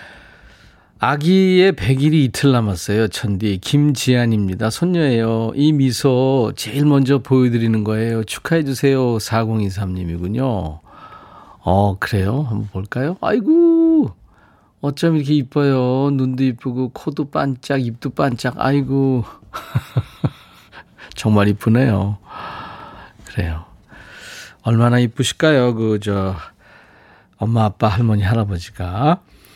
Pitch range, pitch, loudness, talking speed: 105-140 Hz, 120 Hz, -17 LUFS, 235 characters per minute